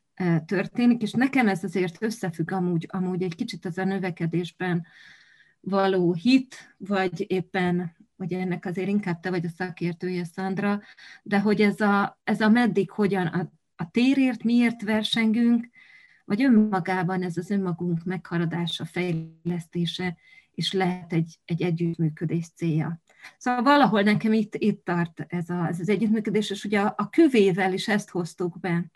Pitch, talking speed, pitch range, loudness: 185 Hz, 150 wpm, 175-210 Hz, -25 LUFS